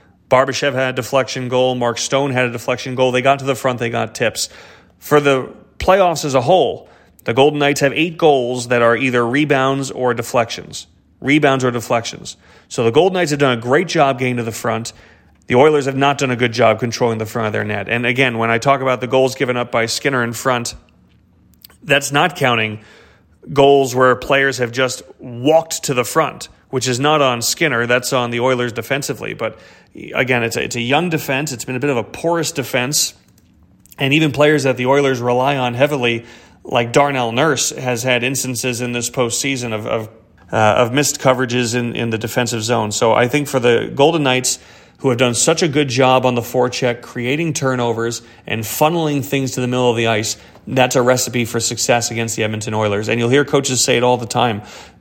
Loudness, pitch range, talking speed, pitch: -16 LUFS, 120-140 Hz, 215 wpm, 125 Hz